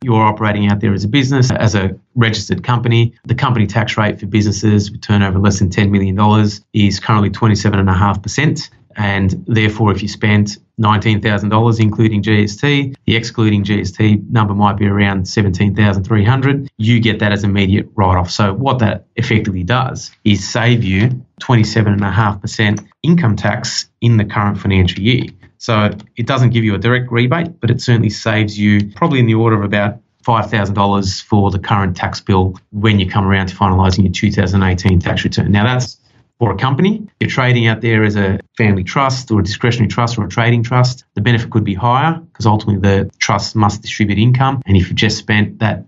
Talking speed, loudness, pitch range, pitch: 185 wpm, -14 LUFS, 100-115 Hz, 105 Hz